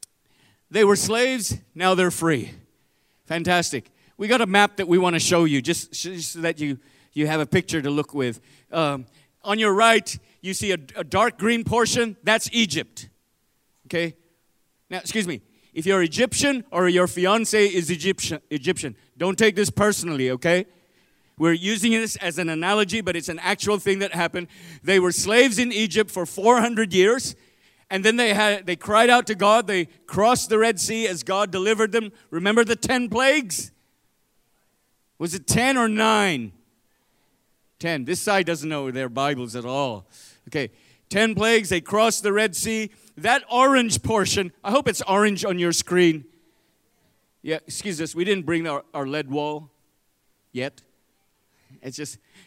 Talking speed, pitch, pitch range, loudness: 170 wpm, 180 Hz, 155-215 Hz, -21 LUFS